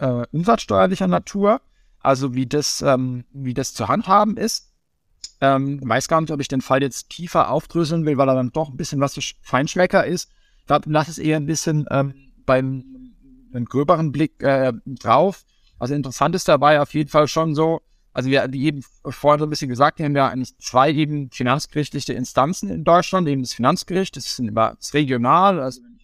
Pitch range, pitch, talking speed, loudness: 130-160 Hz, 145 Hz, 195 wpm, -20 LUFS